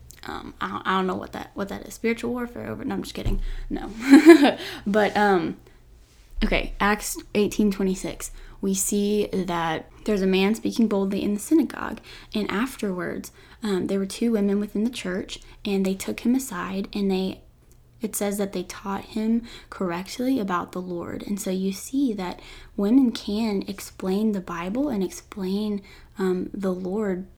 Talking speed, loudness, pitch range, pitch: 175 wpm, -24 LUFS, 190-225 Hz, 205 Hz